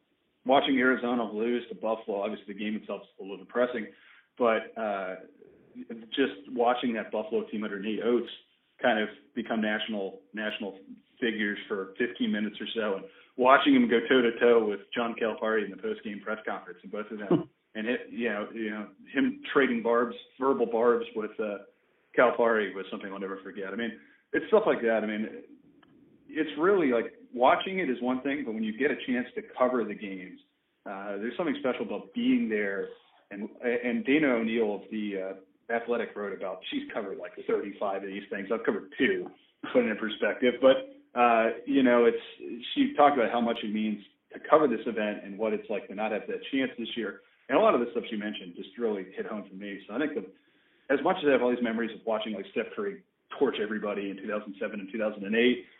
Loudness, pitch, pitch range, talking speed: -29 LUFS, 115 Hz, 105-140 Hz, 210 wpm